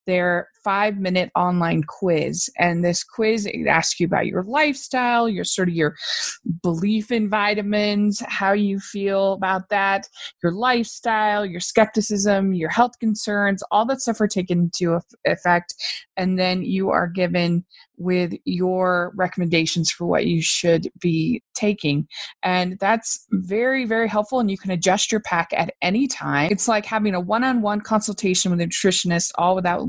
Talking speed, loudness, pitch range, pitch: 155 wpm, -21 LUFS, 180-215 Hz, 195 Hz